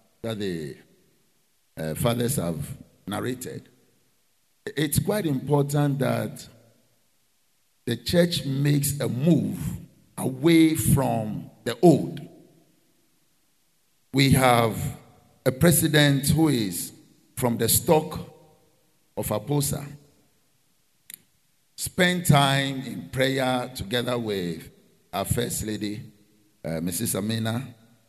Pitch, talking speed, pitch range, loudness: 130 Hz, 90 wpm, 115-145 Hz, -24 LUFS